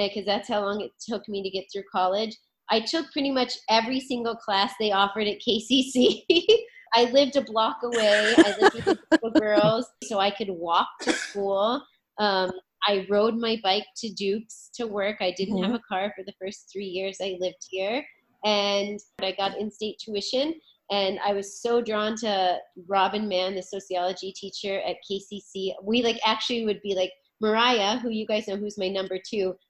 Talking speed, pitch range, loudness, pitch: 190 wpm, 195-230 Hz, -25 LUFS, 205 Hz